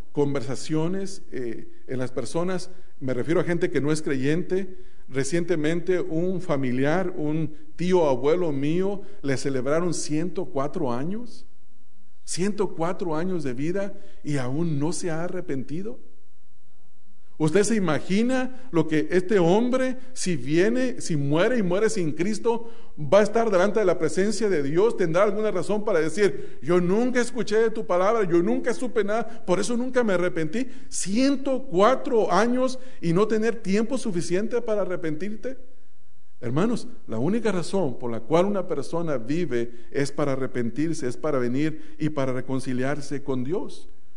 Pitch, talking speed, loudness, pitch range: 180 Hz, 145 wpm, -25 LUFS, 155-215 Hz